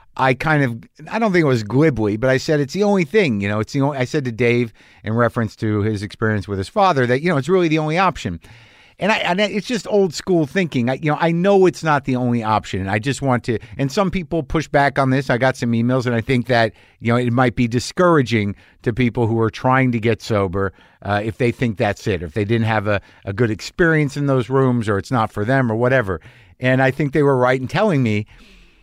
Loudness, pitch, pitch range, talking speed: -18 LUFS, 125 Hz, 110-150 Hz, 260 wpm